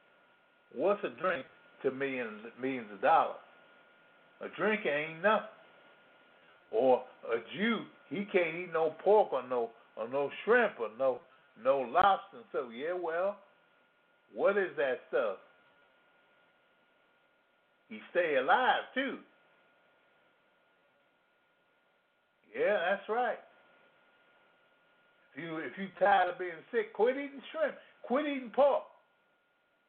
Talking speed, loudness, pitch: 115 wpm, -32 LUFS, 205 Hz